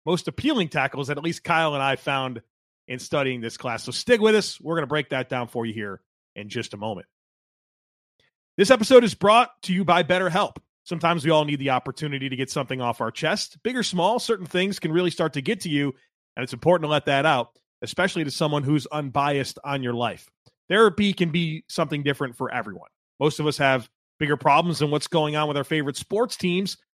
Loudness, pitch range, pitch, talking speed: -23 LUFS, 130-175 Hz, 150 Hz, 225 wpm